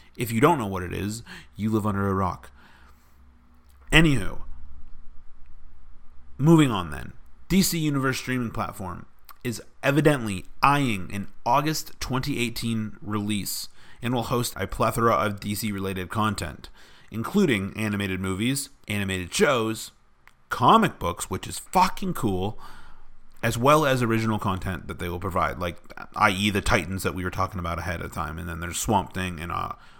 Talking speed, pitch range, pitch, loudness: 150 wpm, 90-120 Hz, 100 Hz, -25 LUFS